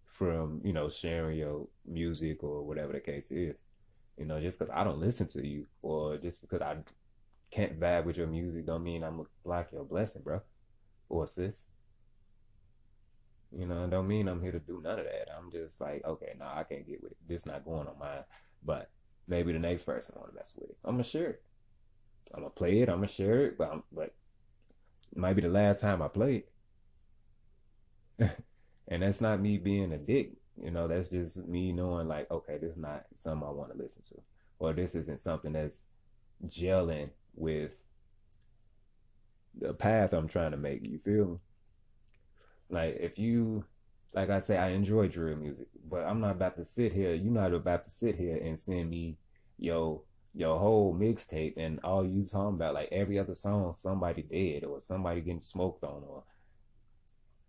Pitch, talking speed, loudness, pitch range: 90 Hz, 200 wpm, -34 LUFS, 80-100 Hz